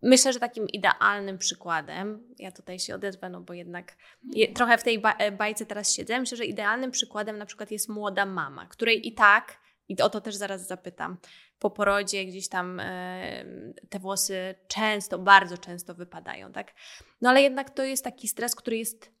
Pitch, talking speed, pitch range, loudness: 210 Hz, 180 wpm, 185-230 Hz, -26 LUFS